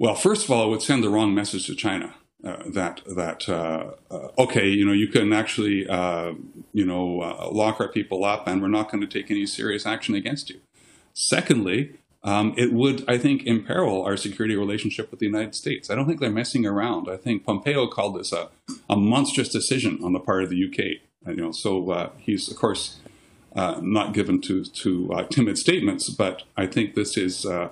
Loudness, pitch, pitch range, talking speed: -24 LUFS, 105 Hz, 95-115 Hz, 215 wpm